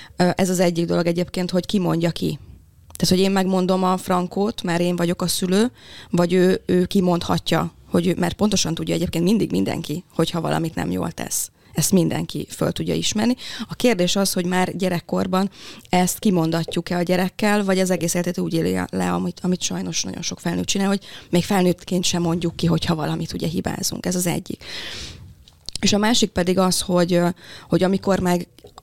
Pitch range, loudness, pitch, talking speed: 170-190 Hz, -21 LUFS, 180 Hz, 185 wpm